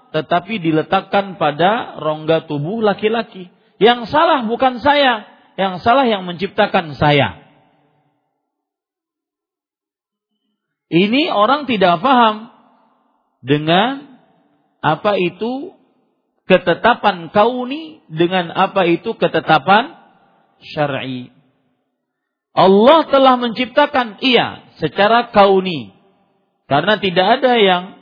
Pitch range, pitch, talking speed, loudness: 175-245 Hz, 205 Hz, 85 wpm, -15 LUFS